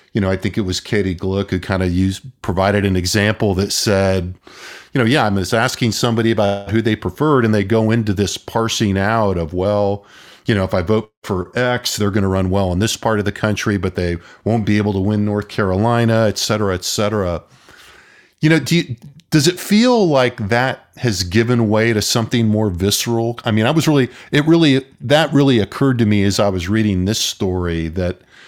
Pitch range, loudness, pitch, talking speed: 100-120 Hz, -17 LUFS, 110 Hz, 215 wpm